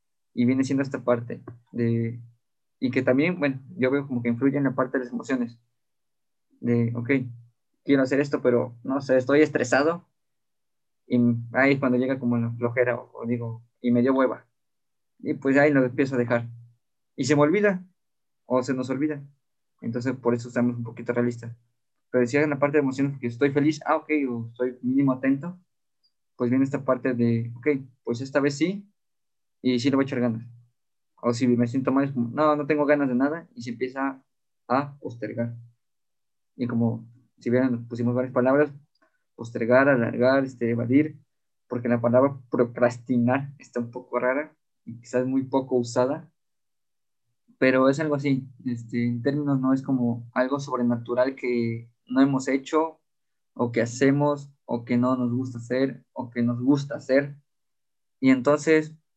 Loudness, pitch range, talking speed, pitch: -25 LUFS, 120-140 Hz, 180 wpm, 130 Hz